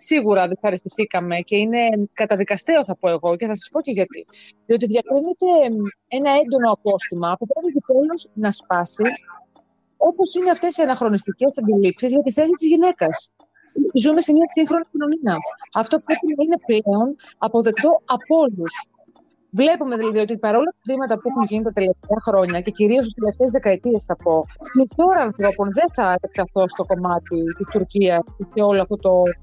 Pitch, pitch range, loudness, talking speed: 225 Hz, 195-295 Hz, -19 LUFS, 165 wpm